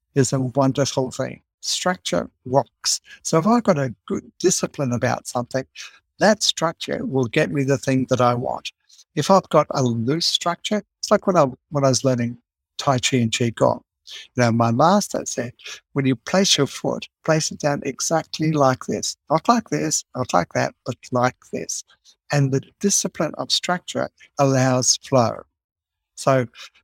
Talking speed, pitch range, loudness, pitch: 170 wpm, 125-160 Hz, -21 LUFS, 140 Hz